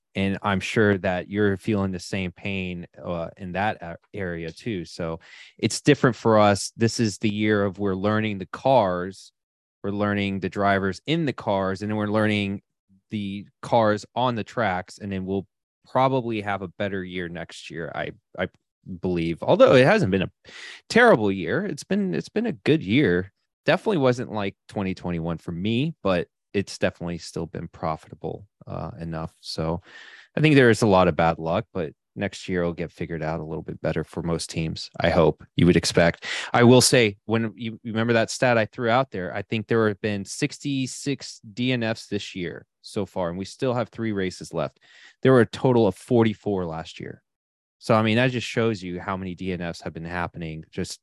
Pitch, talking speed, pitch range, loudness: 100 Hz, 195 wpm, 90-115 Hz, -24 LUFS